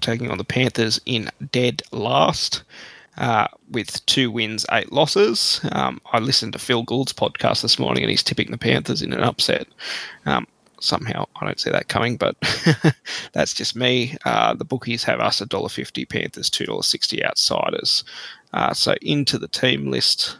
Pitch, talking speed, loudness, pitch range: 125 Hz, 175 wpm, -20 LUFS, 115-130 Hz